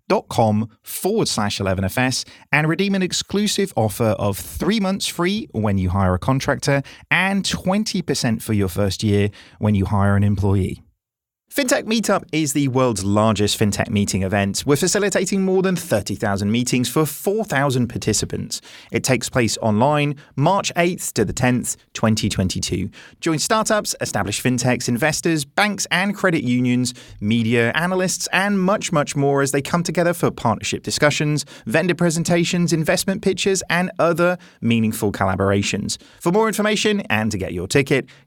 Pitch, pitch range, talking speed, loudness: 140 Hz, 110-180 Hz, 150 wpm, -20 LUFS